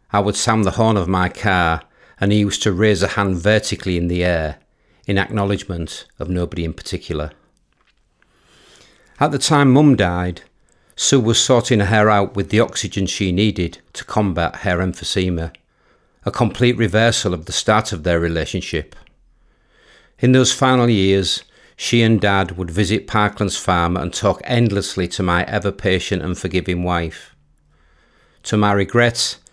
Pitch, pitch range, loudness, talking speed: 95 Hz, 90-105 Hz, -18 LUFS, 155 wpm